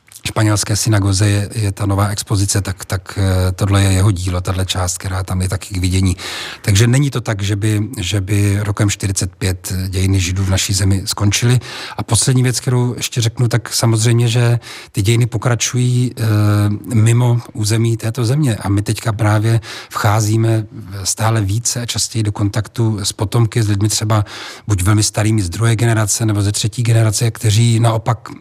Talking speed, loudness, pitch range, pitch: 175 wpm, -16 LUFS, 100-115 Hz, 110 Hz